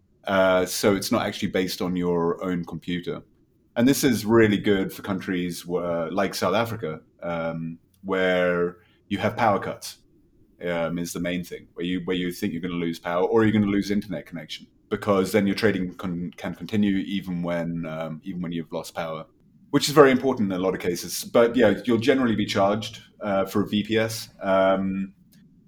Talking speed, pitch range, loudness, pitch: 195 wpm, 85-105 Hz, -24 LUFS, 95 Hz